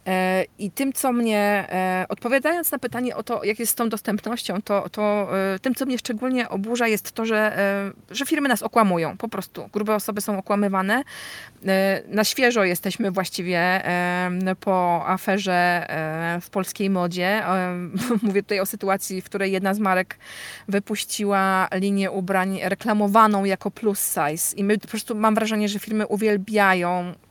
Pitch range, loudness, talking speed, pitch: 190-220 Hz, -22 LUFS, 150 wpm, 200 Hz